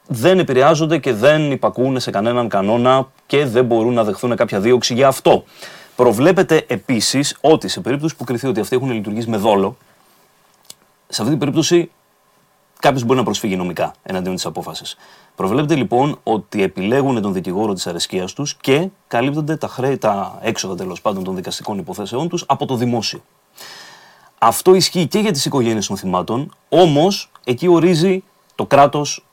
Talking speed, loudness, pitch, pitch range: 160 wpm, -17 LUFS, 135 Hz, 120-160 Hz